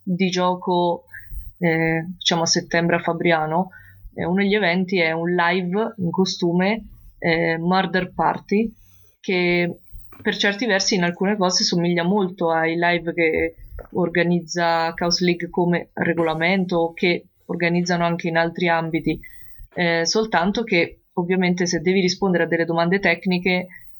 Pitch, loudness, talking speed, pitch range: 175 Hz, -20 LUFS, 135 wpm, 170-185 Hz